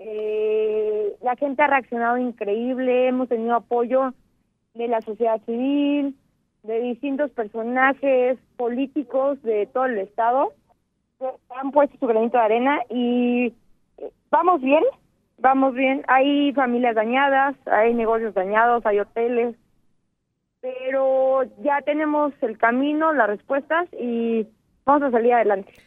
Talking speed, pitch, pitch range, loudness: 125 wpm, 255 Hz, 230-280 Hz, -21 LUFS